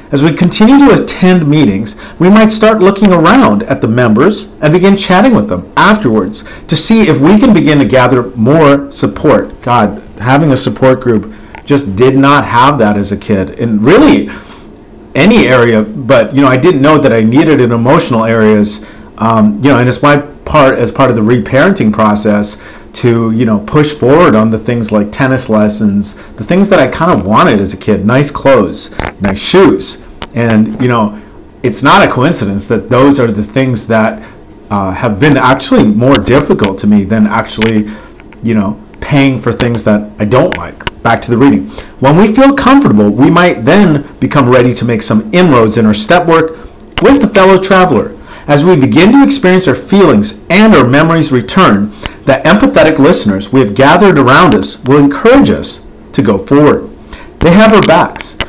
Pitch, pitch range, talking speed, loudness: 125 Hz, 105-150 Hz, 190 wpm, -7 LUFS